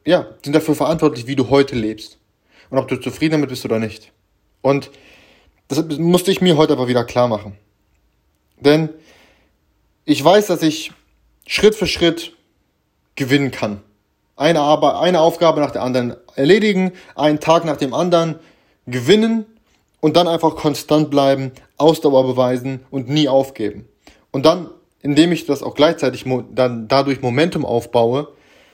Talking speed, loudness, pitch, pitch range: 150 wpm, -17 LUFS, 140 Hz, 125-160 Hz